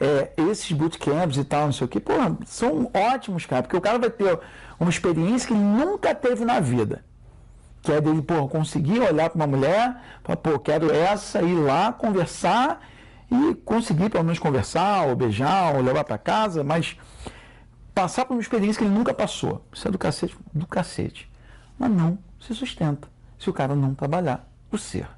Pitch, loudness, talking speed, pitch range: 175 Hz, -23 LUFS, 190 wpm, 150-220 Hz